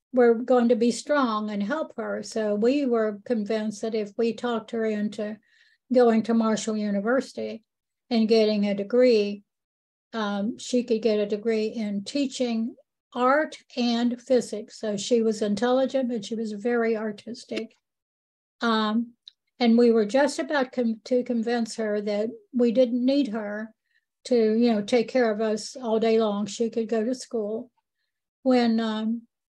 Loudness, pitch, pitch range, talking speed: -25 LUFS, 230 Hz, 215-245 Hz, 160 wpm